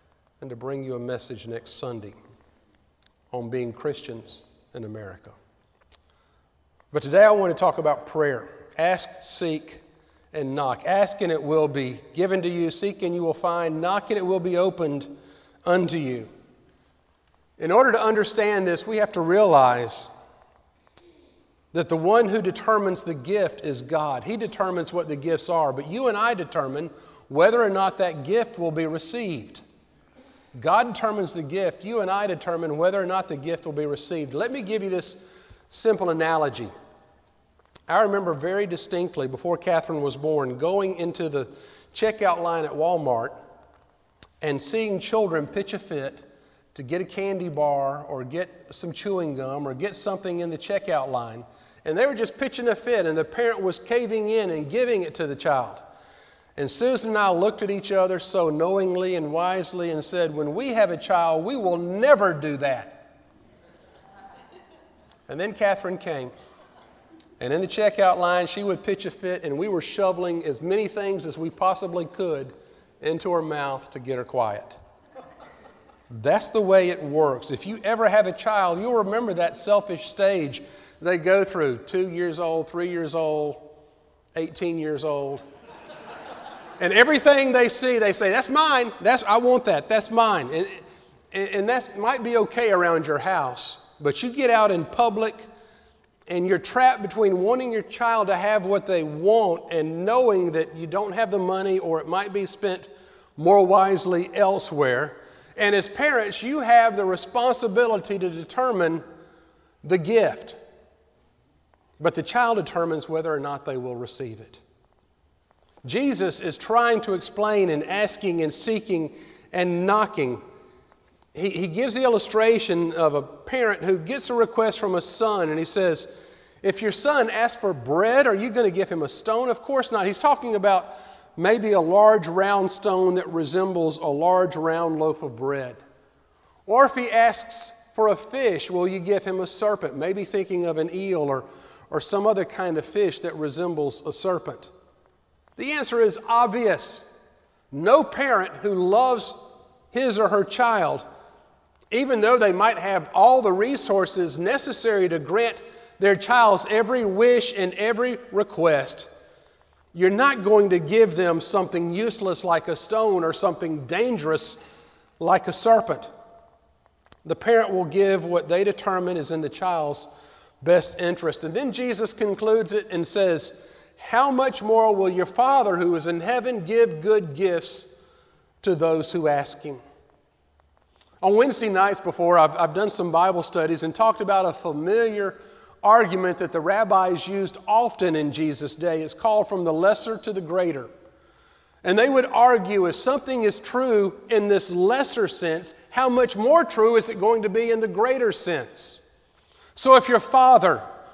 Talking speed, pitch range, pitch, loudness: 170 wpm, 160-220 Hz, 185 Hz, -22 LUFS